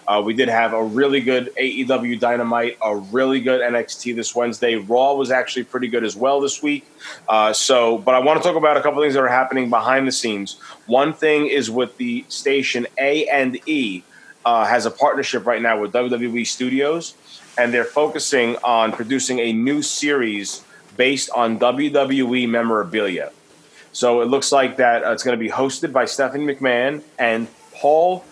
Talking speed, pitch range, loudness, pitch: 185 wpm, 120-140 Hz, -19 LUFS, 130 Hz